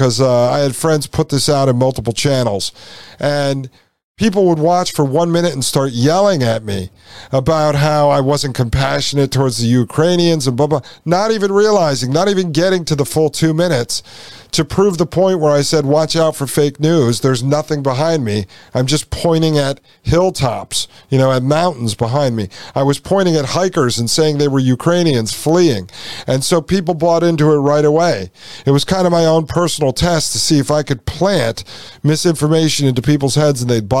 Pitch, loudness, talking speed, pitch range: 145 Hz, -14 LUFS, 200 wpm, 130-165 Hz